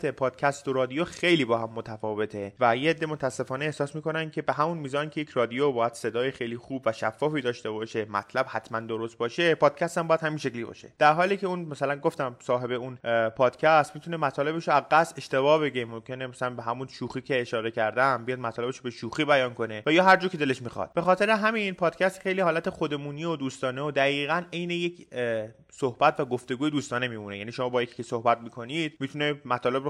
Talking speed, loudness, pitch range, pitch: 200 wpm, -27 LUFS, 120-155 Hz, 135 Hz